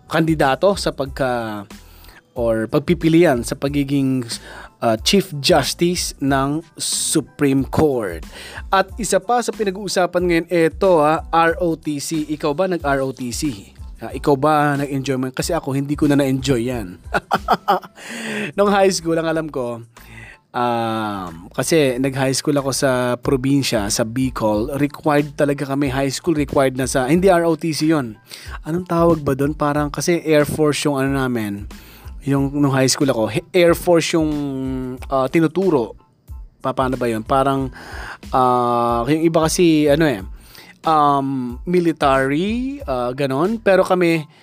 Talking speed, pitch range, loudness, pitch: 140 wpm, 130-165 Hz, -18 LUFS, 145 Hz